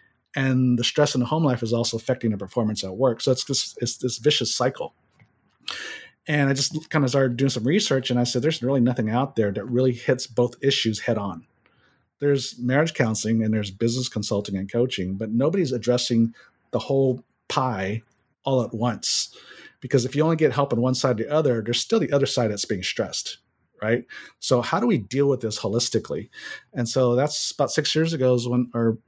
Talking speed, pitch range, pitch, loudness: 210 wpm, 115-135 Hz, 125 Hz, -23 LUFS